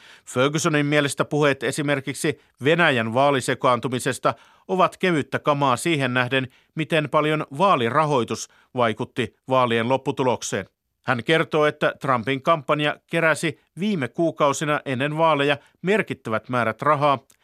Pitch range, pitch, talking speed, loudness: 130-155 Hz, 145 Hz, 105 wpm, -22 LUFS